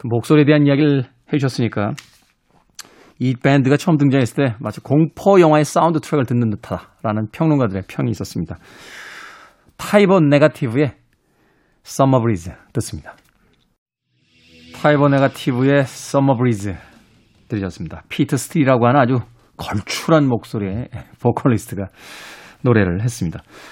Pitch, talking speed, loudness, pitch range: 130 Hz, 320 characters per minute, -17 LUFS, 110-145 Hz